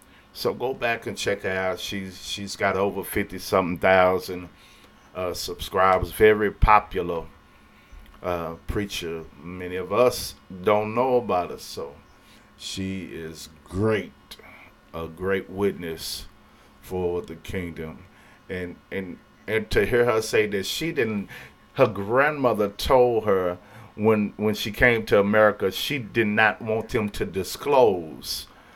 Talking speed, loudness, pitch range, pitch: 135 wpm, -24 LUFS, 90-110 Hz, 100 Hz